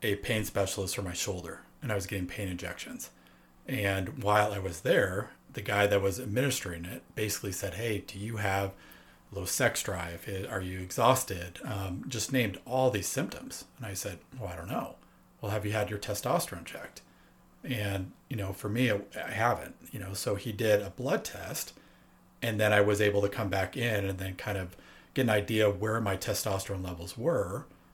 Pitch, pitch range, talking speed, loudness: 100 Hz, 95-110 Hz, 200 wpm, -32 LUFS